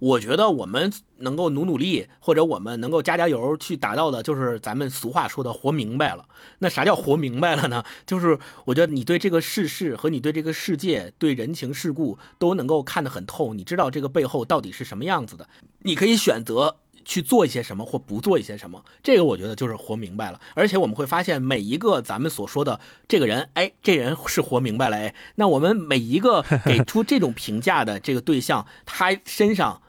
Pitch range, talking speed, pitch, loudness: 125-170 Hz, 330 characters per minute, 155 Hz, -23 LUFS